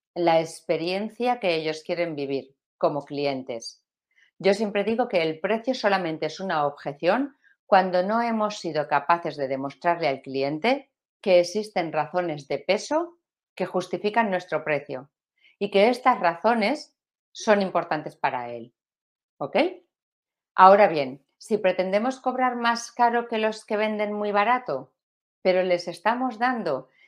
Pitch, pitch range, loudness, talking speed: 185 Hz, 155-225 Hz, -24 LUFS, 135 wpm